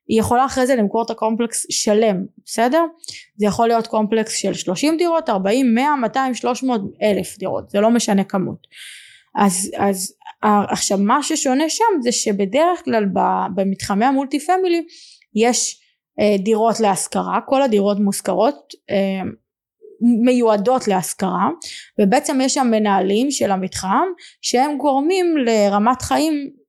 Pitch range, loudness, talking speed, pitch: 205-285 Hz, -18 LUFS, 130 wpm, 235 Hz